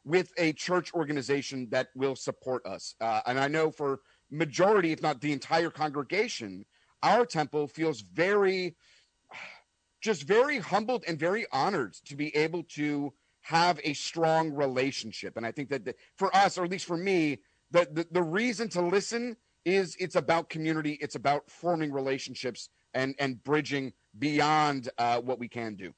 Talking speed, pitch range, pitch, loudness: 165 wpm, 135-175 Hz, 150 Hz, -30 LUFS